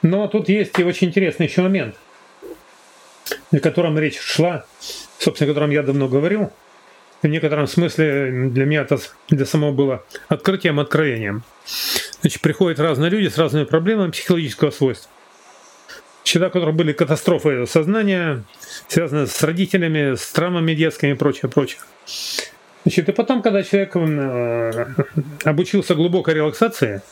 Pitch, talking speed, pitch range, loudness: 160 Hz, 135 wpm, 145-180 Hz, -19 LUFS